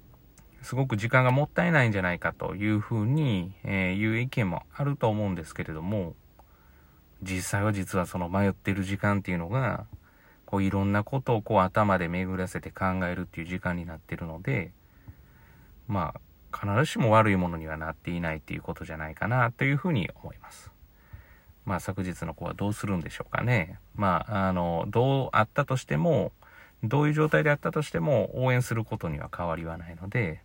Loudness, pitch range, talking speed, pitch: -28 LUFS, 90-120 Hz, 390 characters per minute, 100 Hz